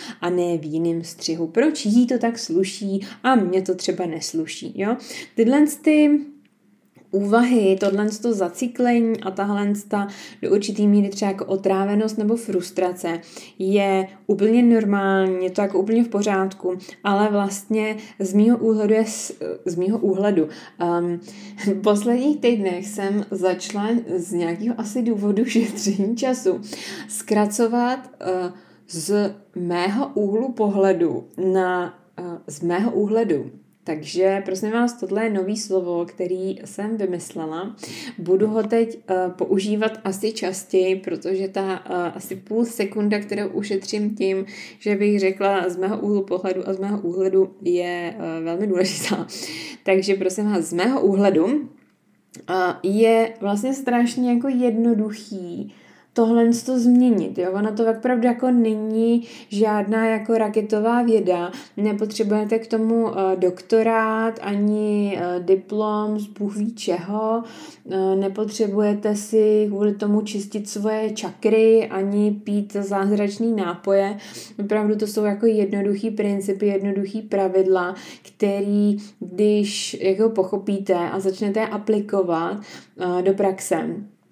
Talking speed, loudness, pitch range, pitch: 125 wpm, -21 LUFS, 190-220 Hz, 205 Hz